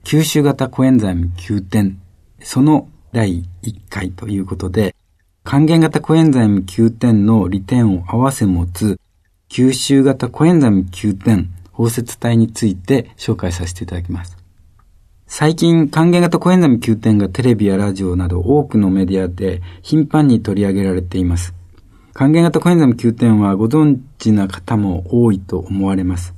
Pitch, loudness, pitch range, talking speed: 105 Hz, -15 LUFS, 95-130 Hz, 305 characters per minute